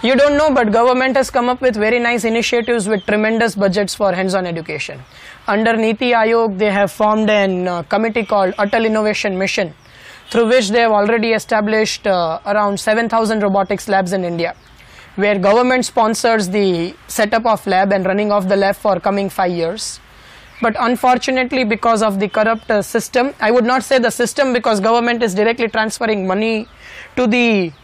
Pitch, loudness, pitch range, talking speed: 220 Hz, -15 LUFS, 200-235 Hz, 175 wpm